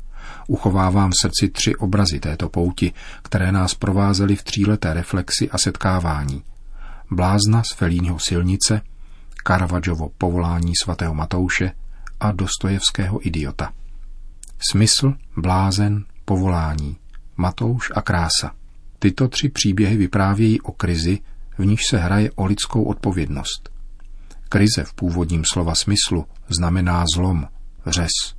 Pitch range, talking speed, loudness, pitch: 85-100 Hz, 110 wpm, -20 LUFS, 95 Hz